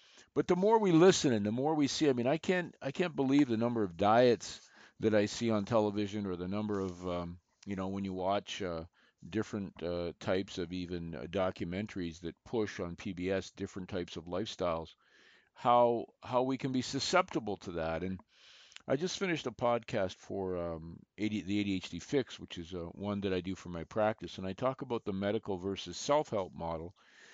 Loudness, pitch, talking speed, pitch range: -34 LUFS, 100 Hz, 200 wpm, 90-120 Hz